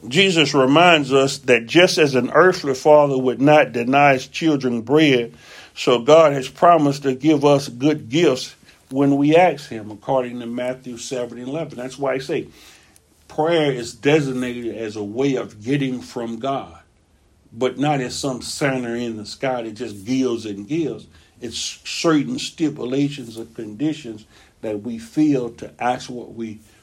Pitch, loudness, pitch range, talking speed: 130 Hz, -19 LUFS, 115-145 Hz, 160 wpm